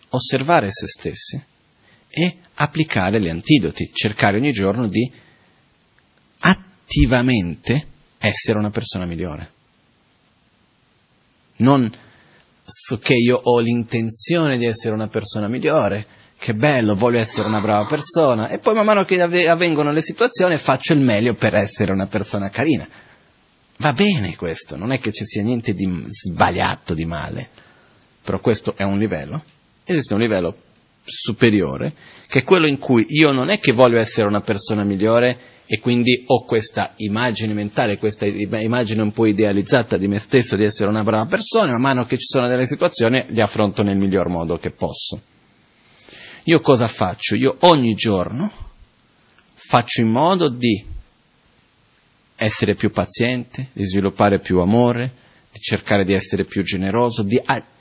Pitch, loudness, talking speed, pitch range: 115 Hz, -18 LUFS, 150 wpm, 105-130 Hz